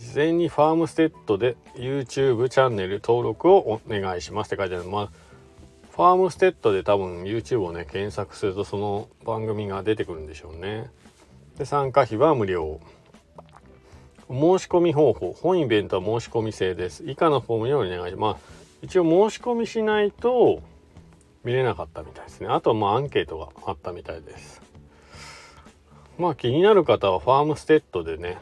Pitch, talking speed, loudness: 110 Hz, 385 characters per minute, -23 LUFS